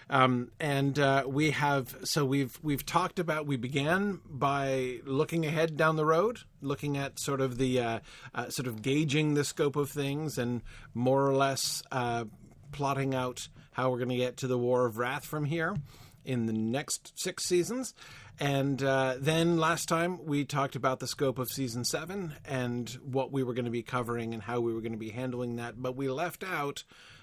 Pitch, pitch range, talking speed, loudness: 135 Hz, 125-150 Hz, 200 wpm, -31 LUFS